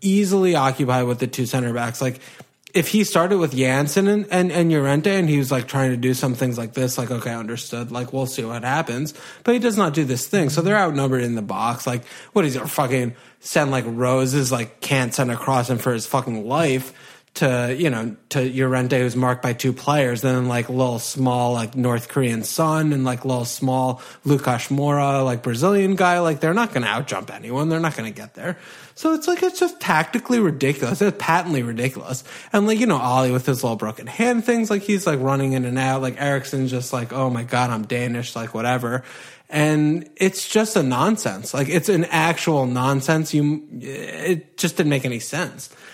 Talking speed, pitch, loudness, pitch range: 210 wpm, 135 Hz, -21 LUFS, 125-165 Hz